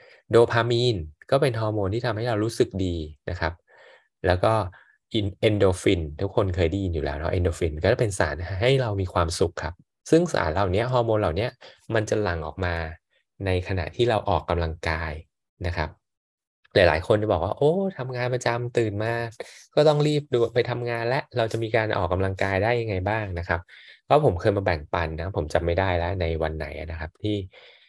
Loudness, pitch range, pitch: -25 LUFS, 85-115 Hz, 95 Hz